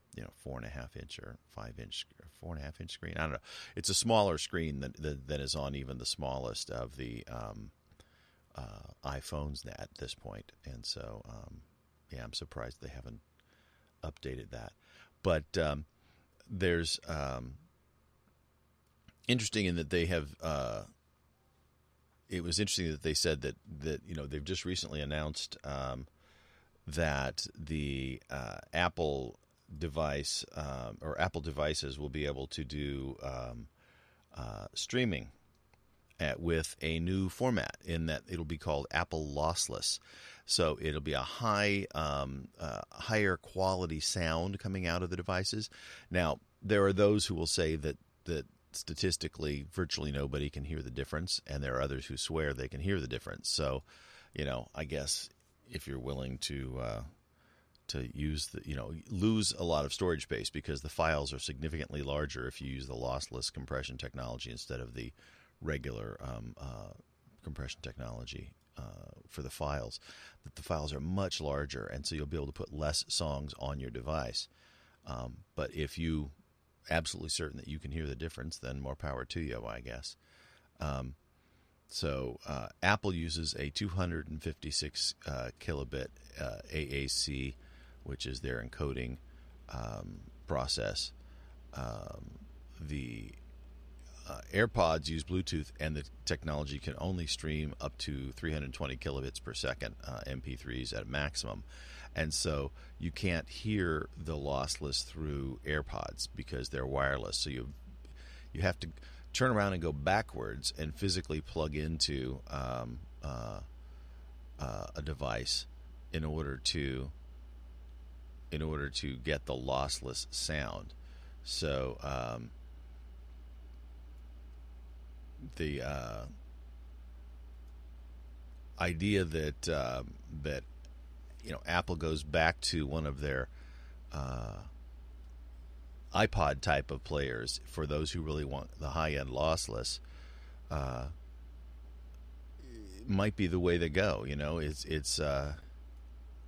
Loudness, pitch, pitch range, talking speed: -36 LUFS, 70 Hz, 65-80 Hz, 145 wpm